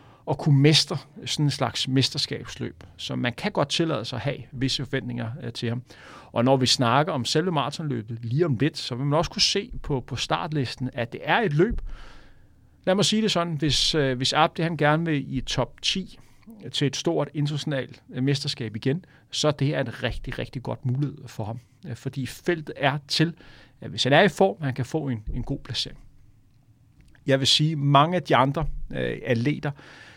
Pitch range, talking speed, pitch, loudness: 125-150 Hz, 195 wpm, 135 Hz, -24 LUFS